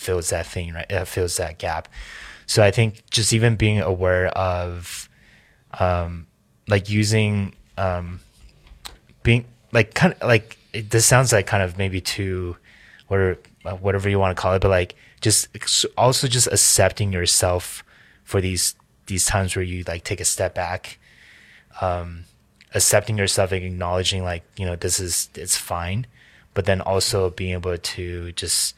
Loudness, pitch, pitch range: -21 LUFS, 95 Hz, 90-105 Hz